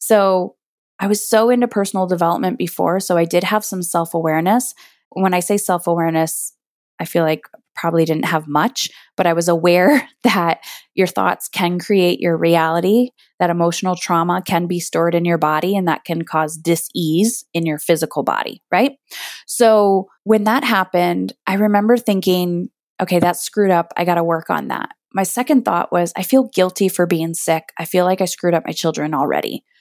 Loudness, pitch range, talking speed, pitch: -17 LUFS, 170-200 Hz, 190 wpm, 175 Hz